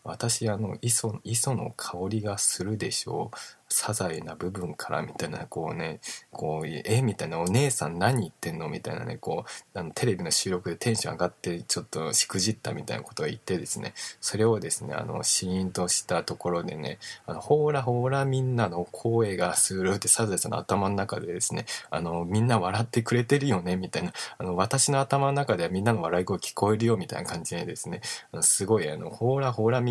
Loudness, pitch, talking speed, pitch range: -27 LUFS, 110 Hz, 415 characters per minute, 90-120 Hz